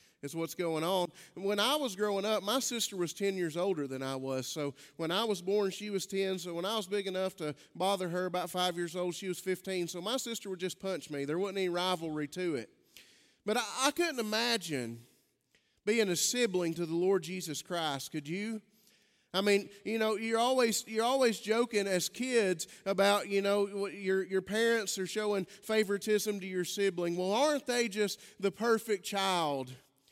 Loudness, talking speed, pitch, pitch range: -33 LUFS, 200 wpm, 195 Hz, 175-215 Hz